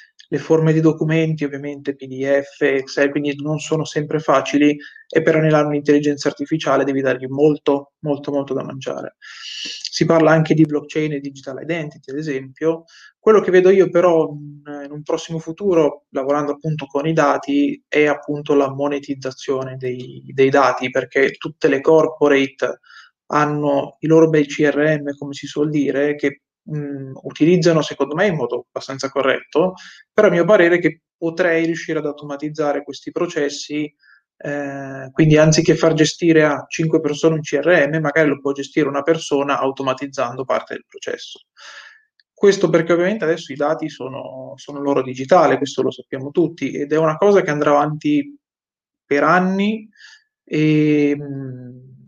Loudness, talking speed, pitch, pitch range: -18 LUFS, 155 wpm, 150 Hz, 140-160 Hz